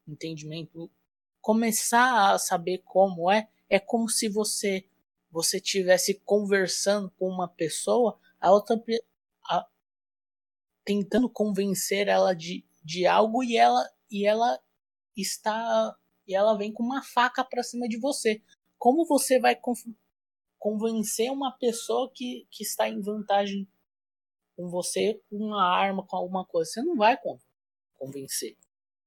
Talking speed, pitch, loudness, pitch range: 135 wpm, 205 Hz, -26 LUFS, 185-230 Hz